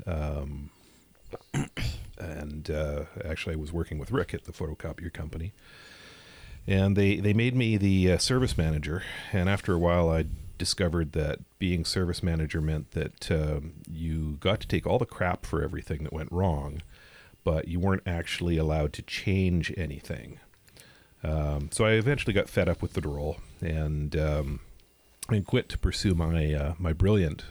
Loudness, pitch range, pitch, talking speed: -29 LUFS, 75-95 Hz, 85 Hz, 165 wpm